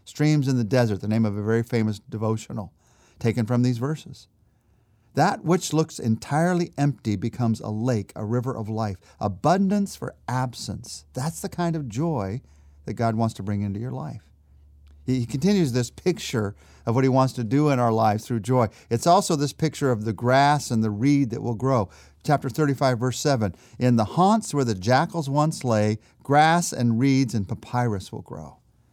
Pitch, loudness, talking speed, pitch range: 120 Hz, -24 LUFS, 185 wpm, 110-145 Hz